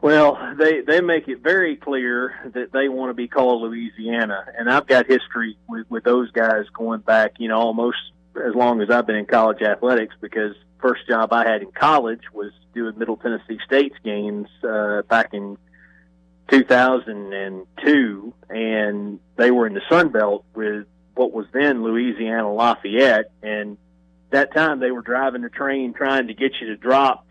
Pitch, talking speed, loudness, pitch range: 115 Hz, 180 wpm, -20 LUFS, 105-130 Hz